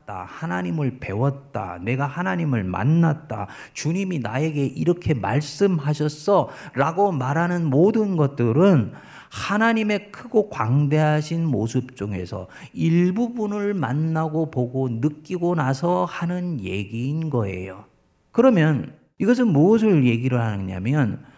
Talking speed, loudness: 260 characters per minute, -22 LUFS